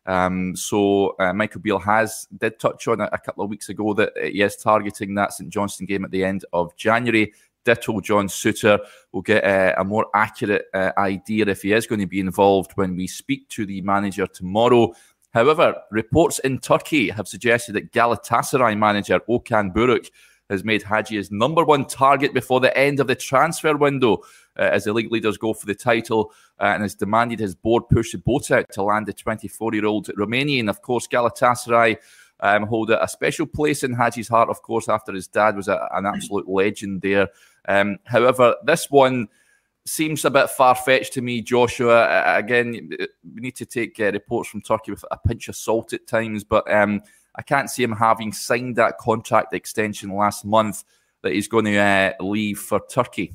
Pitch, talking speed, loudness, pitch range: 110 Hz, 195 wpm, -20 LUFS, 100-120 Hz